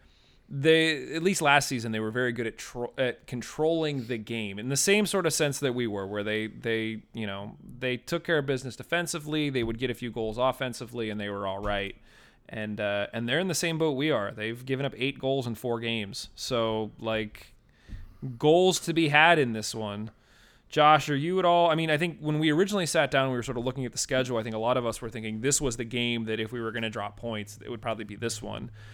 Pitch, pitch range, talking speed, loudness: 120 Hz, 110-145 Hz, 255 wpm, -28 LUFS